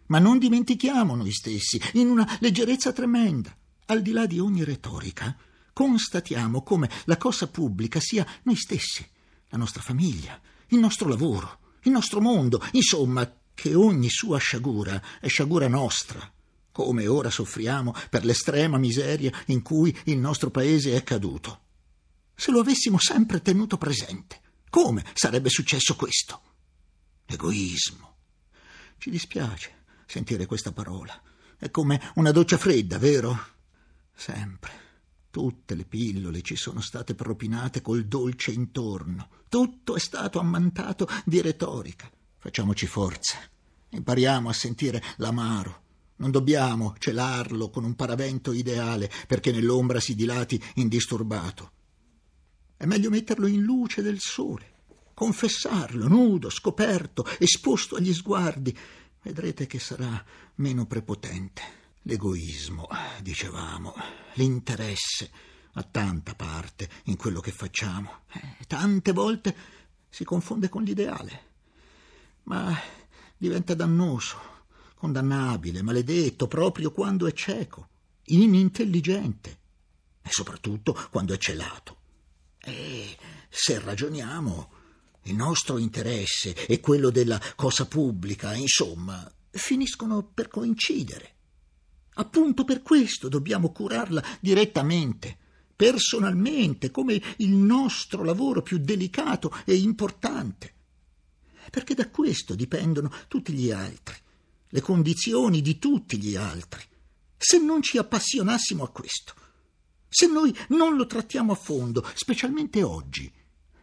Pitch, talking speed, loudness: 130 Hz, 115 wpm, -25 LUFS